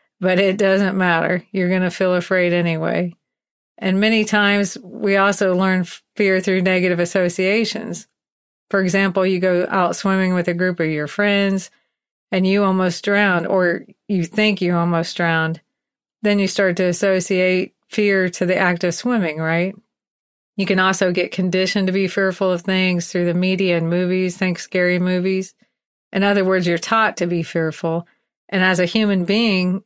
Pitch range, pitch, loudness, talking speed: 180-195 Hz, 185 Hz, -18 LUFS, 170 wpm